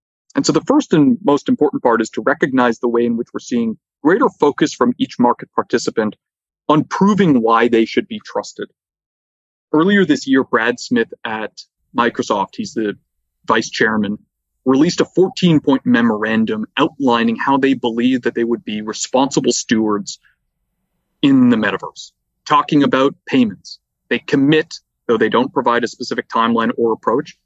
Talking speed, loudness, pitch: 160 wpm, -16 LUFS, 135 Hz